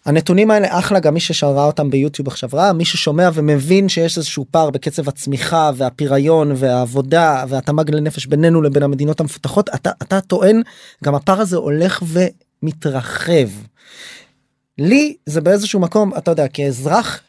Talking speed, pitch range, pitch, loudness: 140 wpm, 140-180 Hz, 155 Hz, -15 LUFS